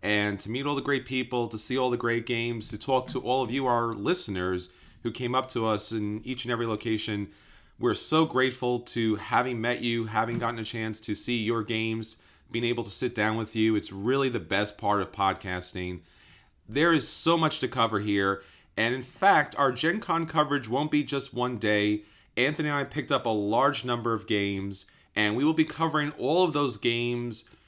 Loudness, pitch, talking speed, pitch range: -27 LUFS, 115 Hz, 210 wpm, 105-130 Hz